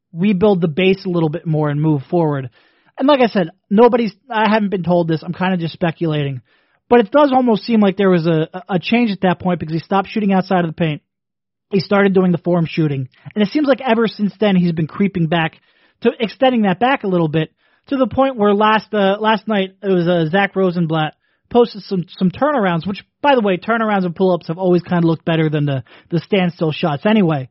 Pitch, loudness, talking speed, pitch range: 185 Hz, -16 LUFS, 240 wpm, 170-215 Hz